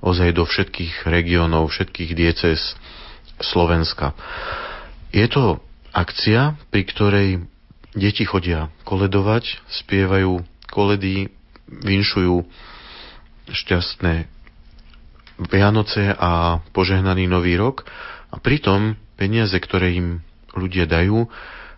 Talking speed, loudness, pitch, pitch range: 85 wpm, -19 LUFS, 95 Hz, 85-100 Hz